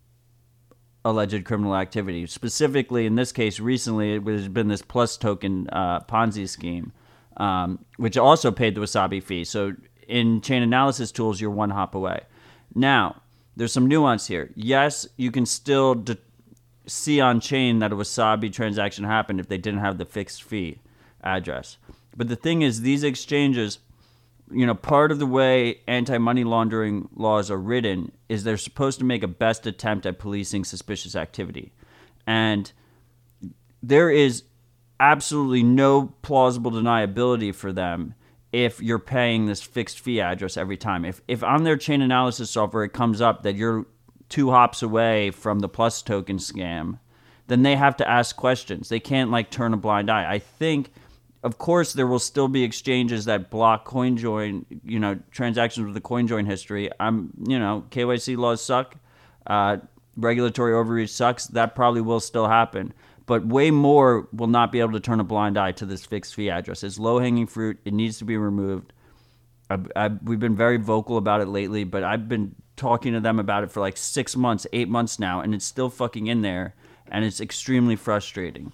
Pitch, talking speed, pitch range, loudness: 115 Hz, 180 wpm, 105-125 Hz, -23 LUFS